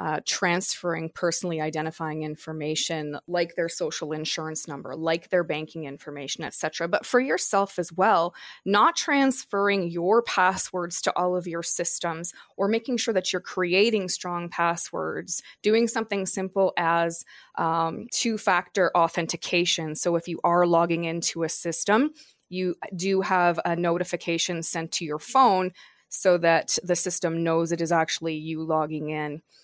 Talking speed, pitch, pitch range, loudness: 150 wpm, 170 Hz, 165-185 Hz, -23 LUFS